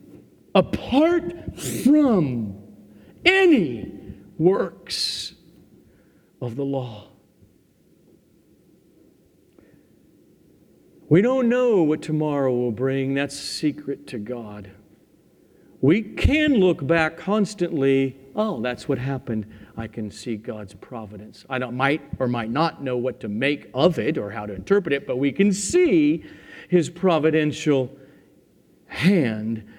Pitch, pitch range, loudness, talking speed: 135 Hz, 115-170 Hz, -22 LUFS, 115 wpm